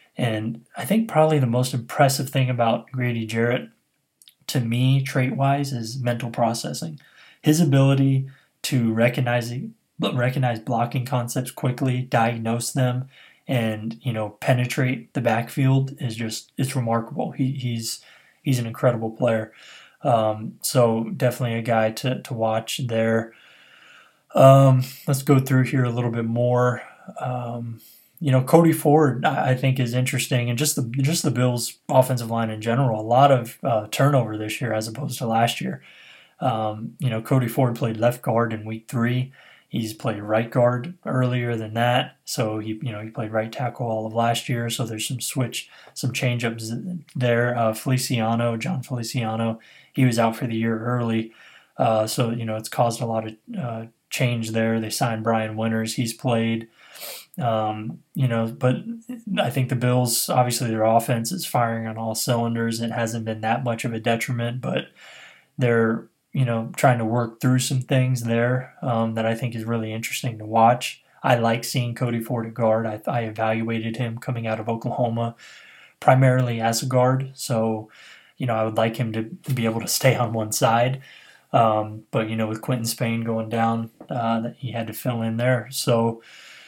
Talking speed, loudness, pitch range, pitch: 175 wpm, -23 LUFS, 115-130 Hz, 120 Hz